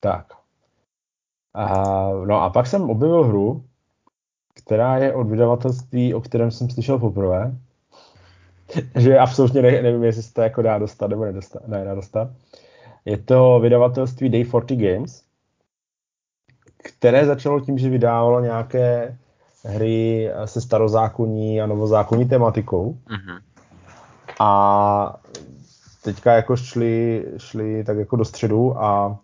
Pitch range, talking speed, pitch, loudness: 105-125 Hz, 120 wpm, 115 Hz, -19 LUFS